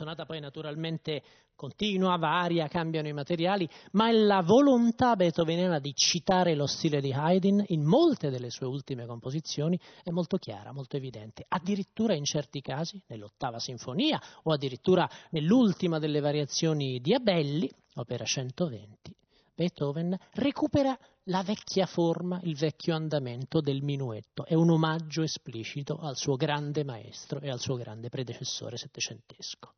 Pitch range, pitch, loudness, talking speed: 140-180 Hz, 155 Hz, -29 LUFS, 140 wpm